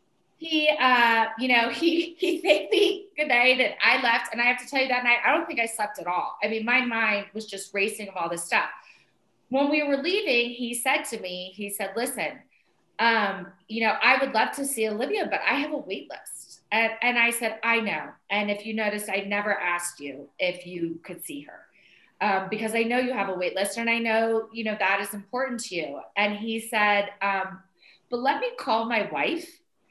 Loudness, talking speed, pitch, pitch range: -25 LUFS, 225 wpm, 225 Hz, 200-255 Hz